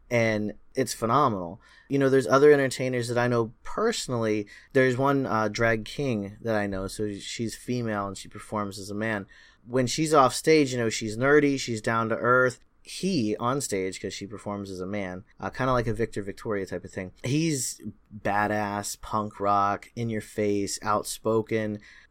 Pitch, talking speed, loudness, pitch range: 110 Hz, 185 wpm, -26 LUFS, 100-125 Hz